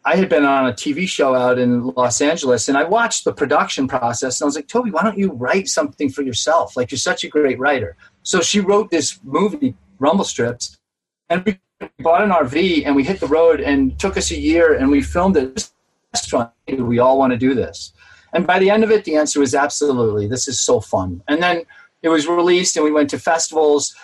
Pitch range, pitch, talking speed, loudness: 130-185 Hz, 150 Hz, 225 wpm, -17 LUFS